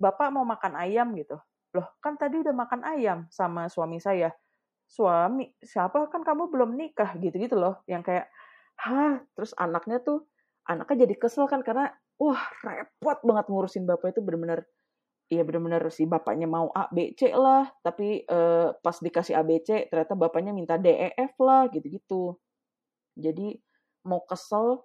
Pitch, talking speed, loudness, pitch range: 210 Hz, 160 wpm, -27 LUFS, 170-265 Hz